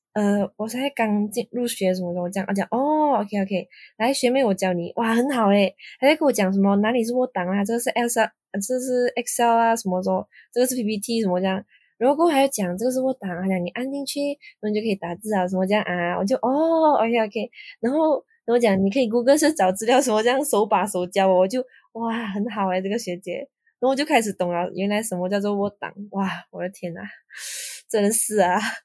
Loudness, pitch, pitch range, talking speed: -22 LUFS, 215 Hz, 190-250 Hz, 370 characters per minute